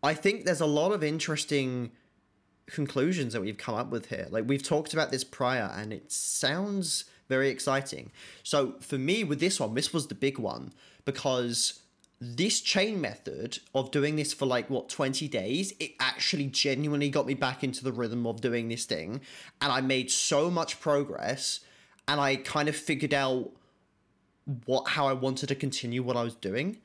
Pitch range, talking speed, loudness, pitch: 125-150 Hz, 185 wpm, -30 LUFS, 135 Hz